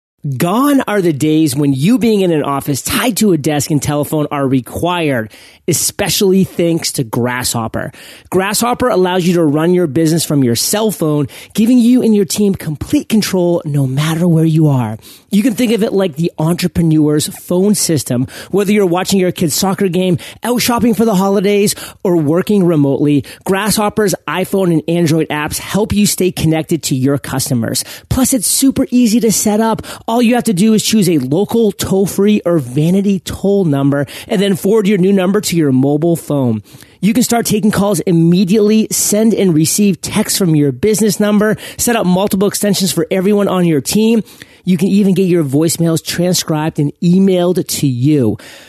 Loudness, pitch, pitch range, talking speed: -13 LUFS, 180 Hz, 155-205 Hz, 180 wpm